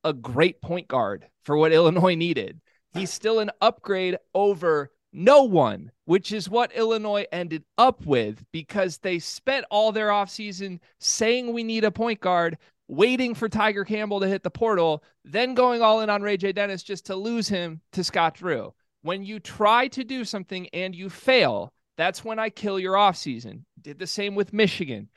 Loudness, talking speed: -24 LUFS, 185 wpm